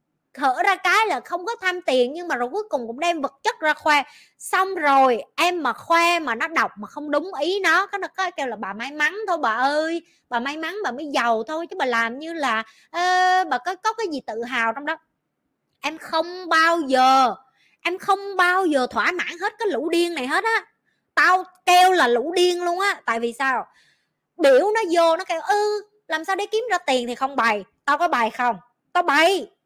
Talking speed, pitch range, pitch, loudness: 235 wpm, 265-370 Hz, 330 Hz, -21 LUFS